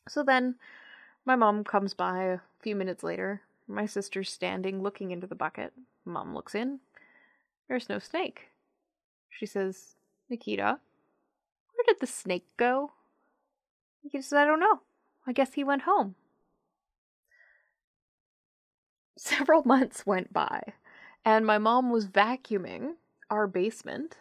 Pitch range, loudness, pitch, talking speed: 195-280 Hz, -29 LUFS, 235 Hz, 130 wpm